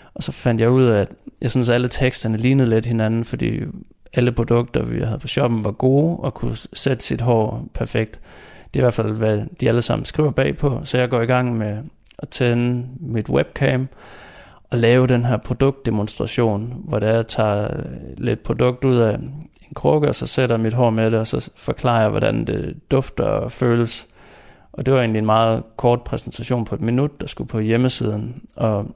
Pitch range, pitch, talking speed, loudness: 110-130 Hz, 120 Hz, 205 wpm, -20 LUFS